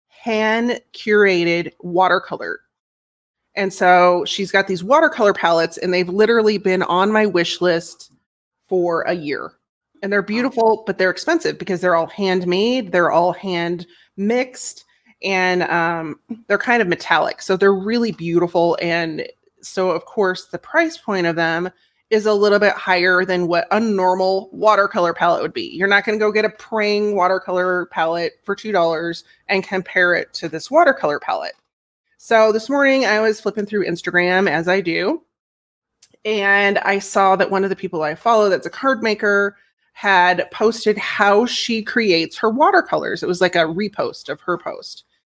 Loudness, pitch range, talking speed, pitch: -18 LUFS, 180-215 Hz, 165 wpm, 195 Hz